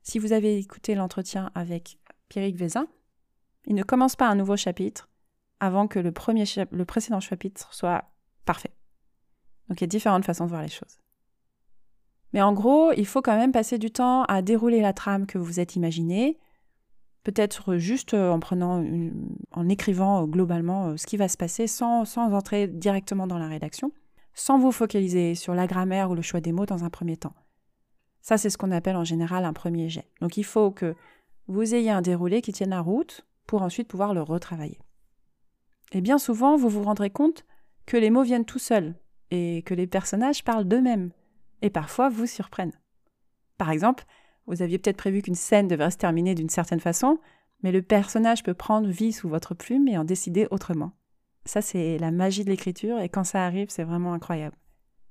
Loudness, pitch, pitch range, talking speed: -25 LUFS, 195 Hz, 175-225 Hz, 195 wpm